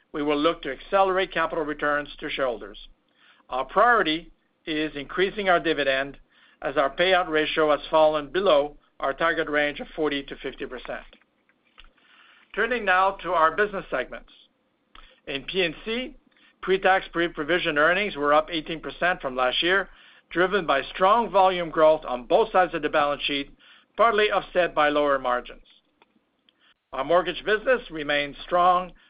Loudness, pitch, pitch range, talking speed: -24 LUFS, 165 Hz, 145-185 Hz, 150 wpm